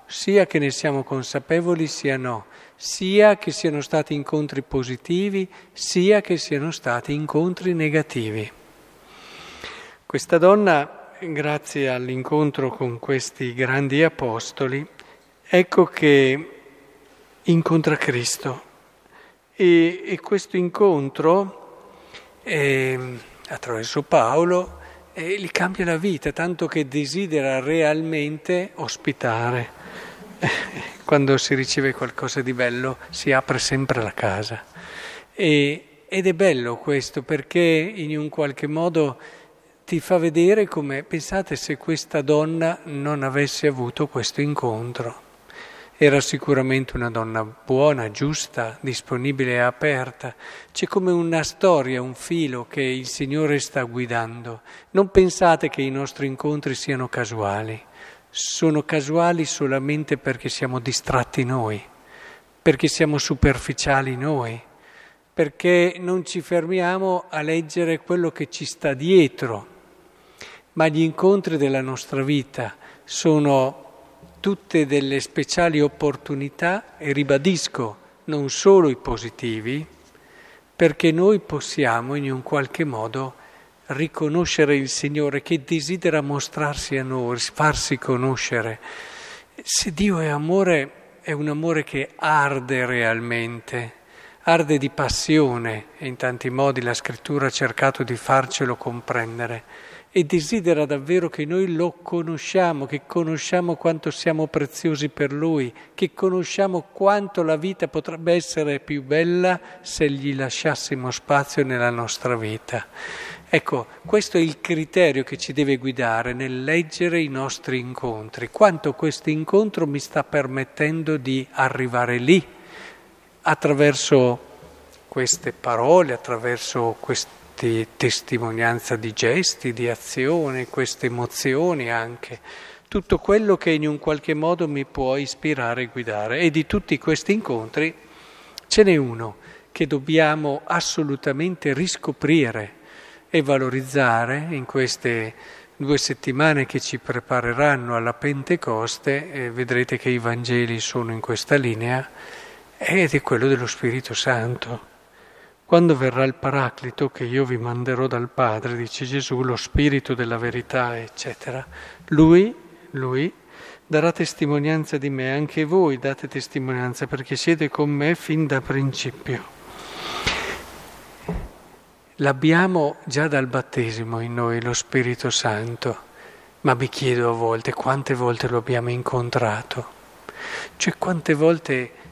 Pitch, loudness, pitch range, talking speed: 145 Hz, -22 LUFS, 130-165 Hz, 120 wpm